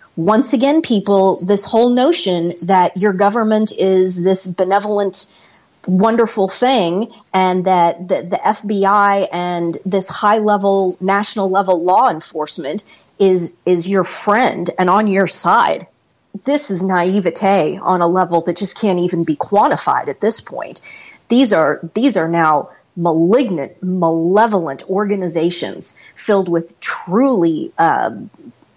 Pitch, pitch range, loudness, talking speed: 195 Hz, 175-210 Hz, -15 LUFS, 130 wpm